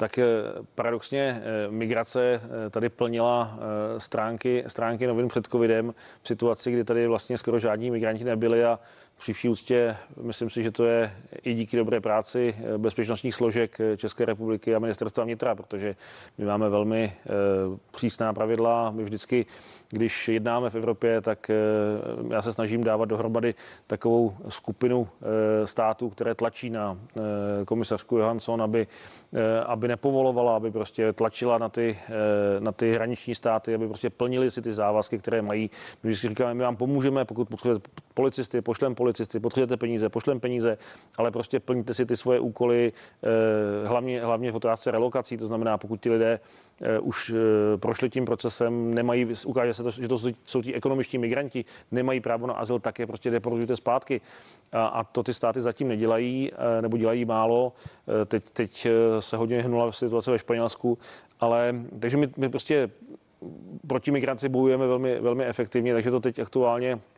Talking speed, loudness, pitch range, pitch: 155 wpm, -27 LUFS, 110-120 Hz, 115 Hz